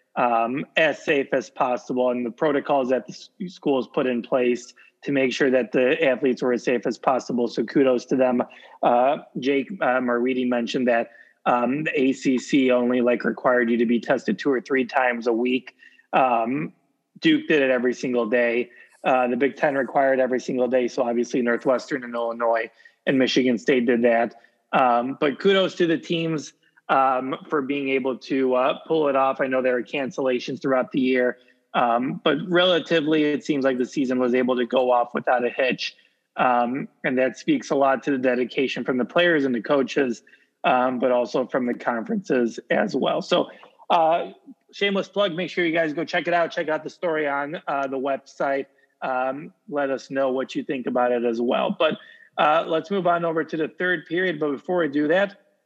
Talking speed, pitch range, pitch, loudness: 200 wpm, 125-155 Hz, 130 Hz, -23 LUFS